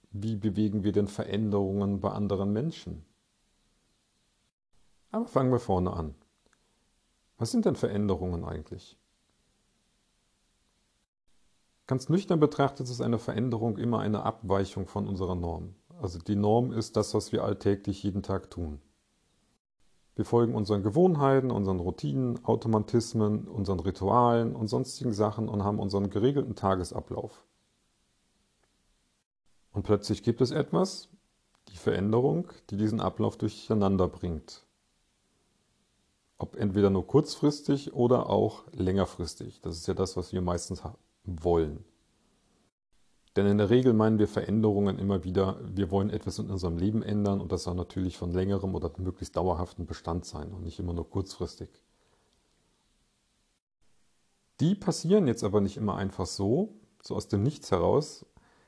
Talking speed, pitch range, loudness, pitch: 135 wpm, 95-115 Hz, -29 LUFS, 100 Hz